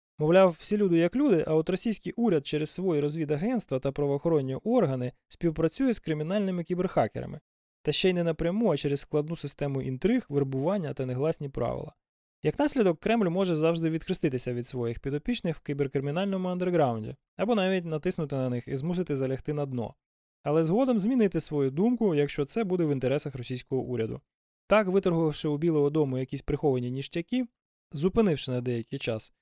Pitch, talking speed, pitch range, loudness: 155 Hz, 160 wpm, 140-185 Hz, -28 LUFS